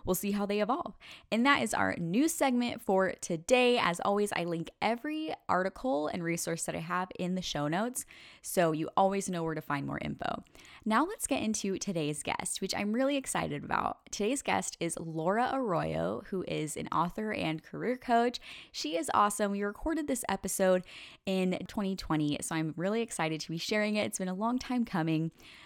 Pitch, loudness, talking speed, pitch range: 195 Hz, -32 LUFS, 195 wpm, 170-240 Hz